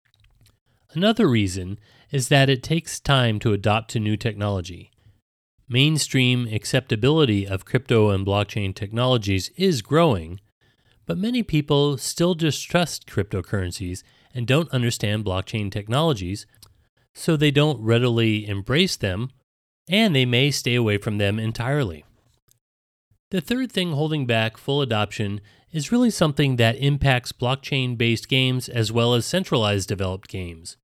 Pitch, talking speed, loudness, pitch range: 120 Hz, 130 wpm, -22 LUFS, 105-145 Hz